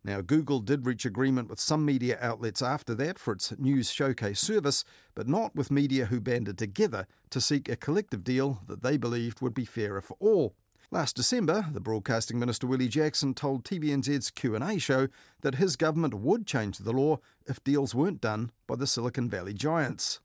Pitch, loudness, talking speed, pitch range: 130 Hz, -29 LUFS, 185 wpm, 115-145 Hz